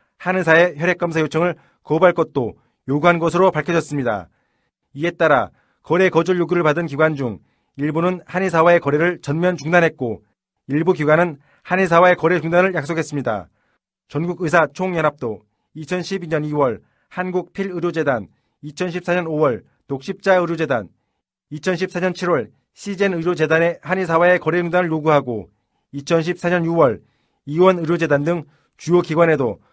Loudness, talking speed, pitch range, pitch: -18 LUFS, 295 characters per minute, 150-180 Hz, 170 Hz